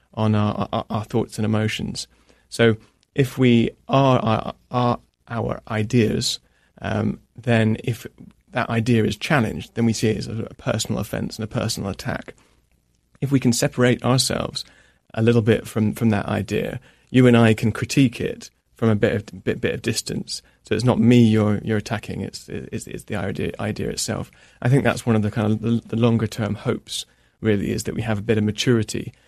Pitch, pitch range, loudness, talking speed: 115 Hz, 105-120 Hz, -22 LUFS, 200 wpm